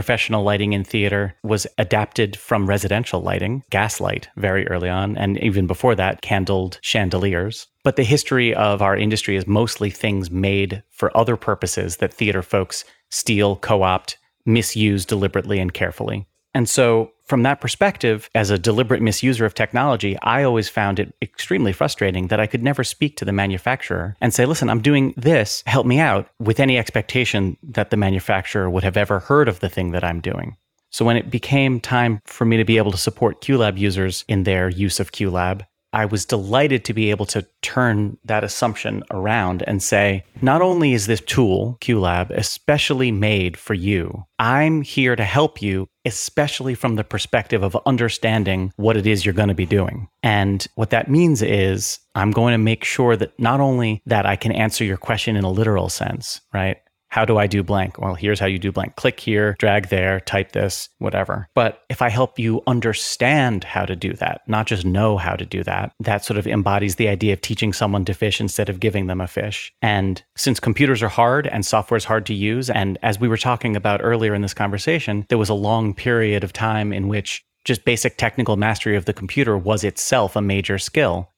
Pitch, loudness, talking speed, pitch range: 105 Hz, -19 LUFS, 200 wpm, 100-120 Hz